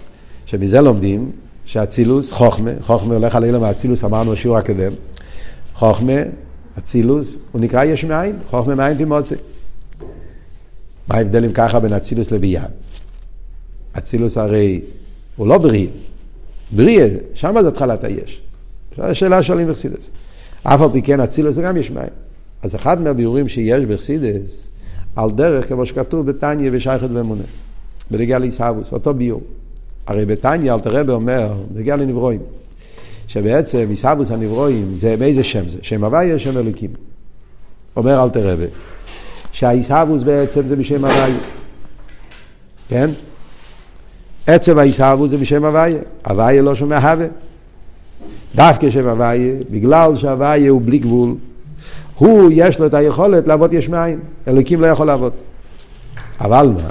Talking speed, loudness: 130 wpm, -14 LUFS